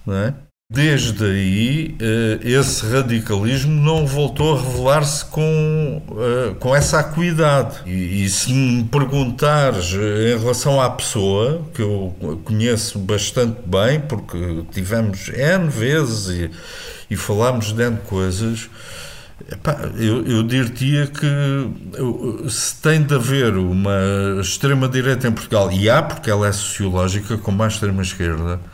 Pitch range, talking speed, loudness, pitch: 100-140 Hz, 125 wpm, -18 LUFS, 120 Hz